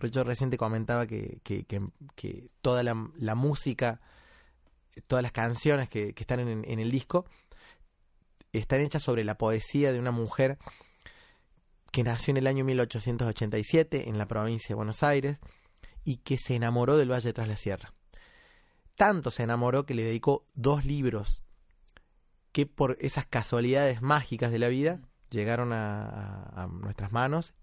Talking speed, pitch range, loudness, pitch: 155 wpm, 110-135 Hz, -30 LUFS, 120 Hz